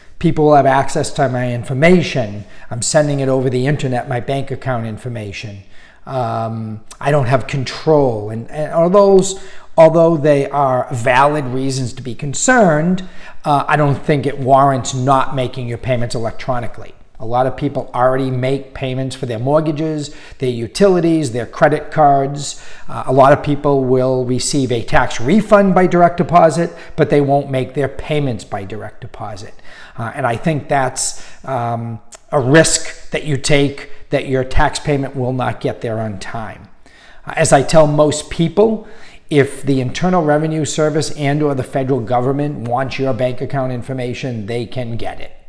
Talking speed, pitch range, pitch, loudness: 170 wpm, 125-150 Hz, 135 Hz, -15 LUFS